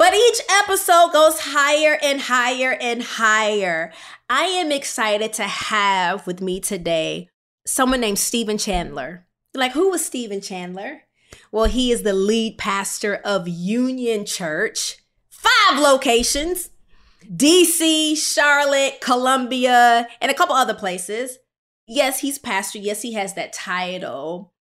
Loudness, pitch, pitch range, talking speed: -18 LUFS, 240 Hz, 200-285 Hz, 130 wpm